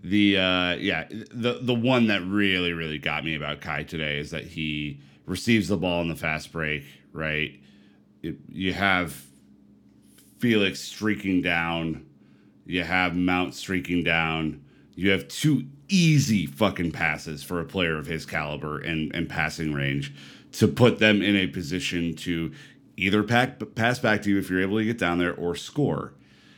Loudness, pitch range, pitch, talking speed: -25 LUFS, 75-100 Hz, 85 Hz, 165 wpm